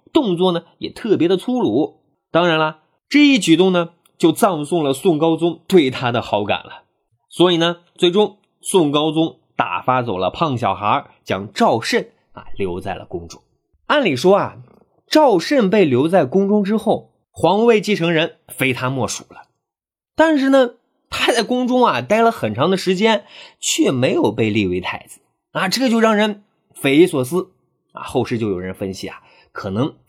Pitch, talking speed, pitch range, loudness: 180 Hz, 240 characters per minute, 150-225 Hz, -17 LUFS